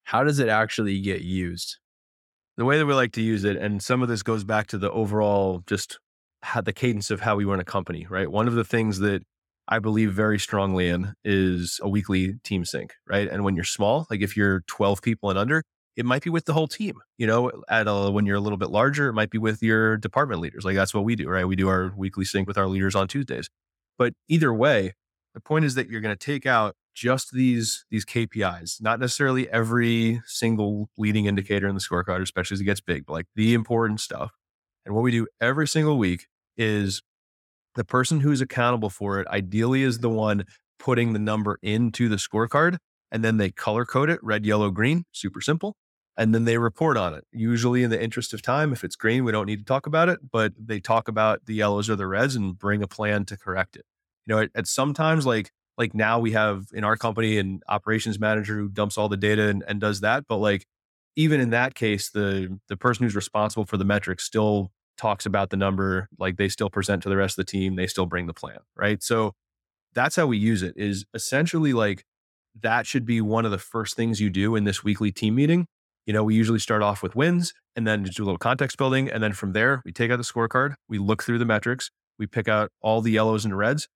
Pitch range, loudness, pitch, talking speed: 100-115 Hz, -24 LUFS, 110 Hz, 235 wpm